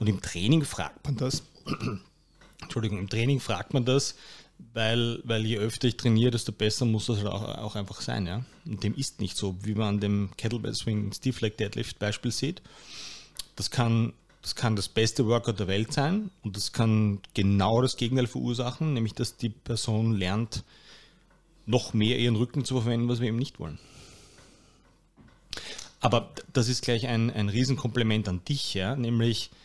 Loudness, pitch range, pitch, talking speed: -28 LUFS, 105-125 Hz, 115 Hz, 180 wpm